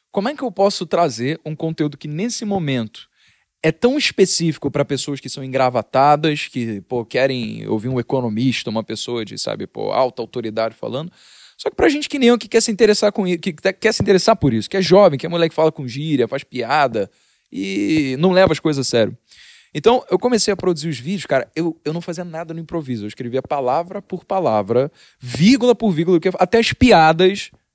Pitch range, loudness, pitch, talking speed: 130-195 Hz, -18 LUFS, 160 Hz, 210 wpm